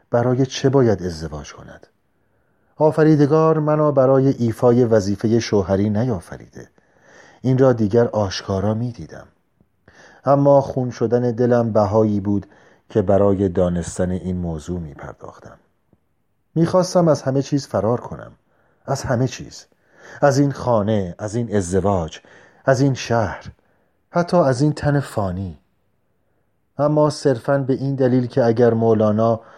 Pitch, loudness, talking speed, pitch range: 120 Hz, -18 LUFS, 125 wpm, 100-135 Hz